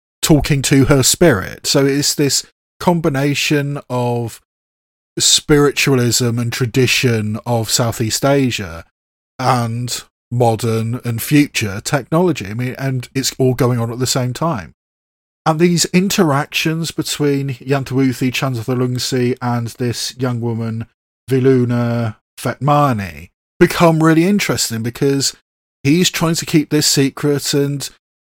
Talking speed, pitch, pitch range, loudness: 115 wpm, 130 Hz, 120-145 Hz, -16 LUFS